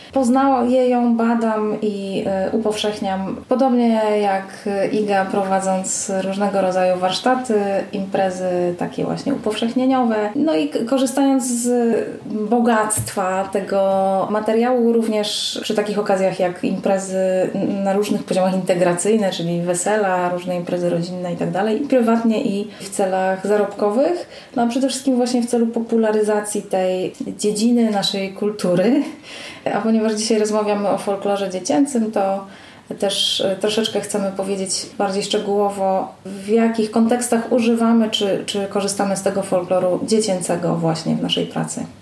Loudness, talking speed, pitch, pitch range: -19 LUFS, 125 wpm, 210 Hz, 195-230 Hz